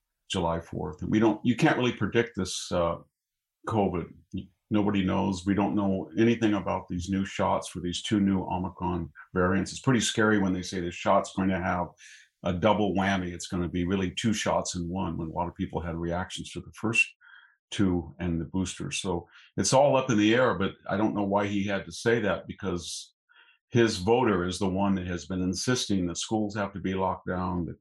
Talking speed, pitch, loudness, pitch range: 215 wpm, 95 Hz, -28 LUFS, 90-105 Hz